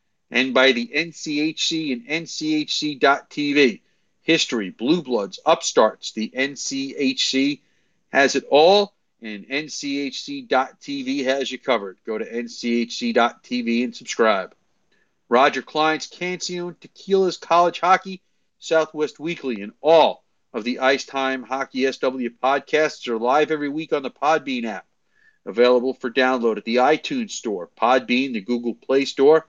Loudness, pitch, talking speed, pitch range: -21 LUFS, 145 Hz, 125 wpm, 125-180 Hz